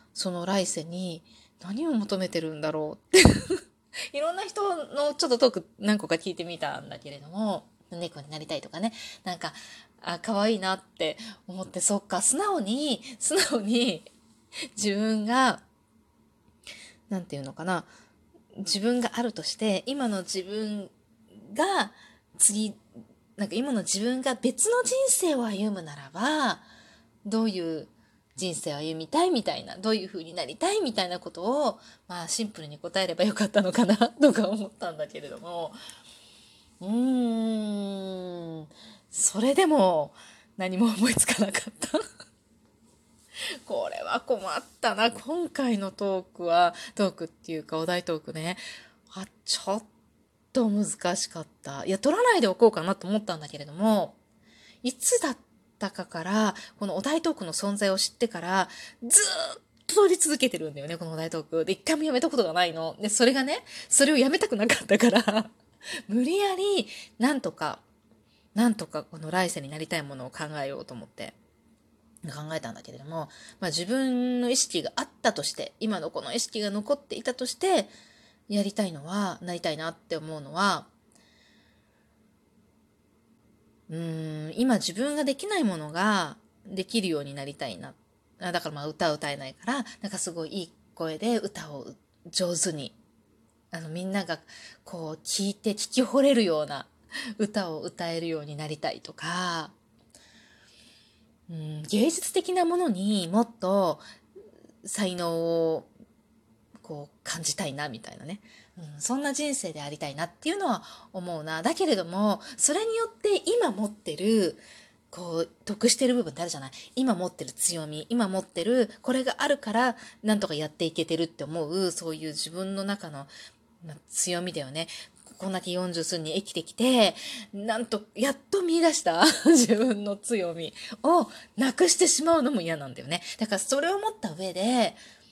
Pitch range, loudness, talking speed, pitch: 165-245 Hz, -27 LUFS, 305 characters per minute, 200 Hz